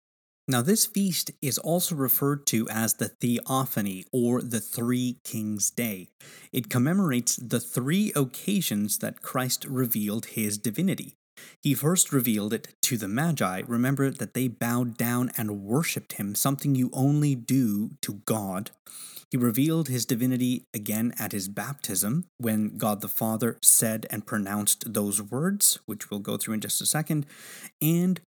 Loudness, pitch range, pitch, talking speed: -26 LUFS, 110-145 Hz, 125 Hz, 150 wpm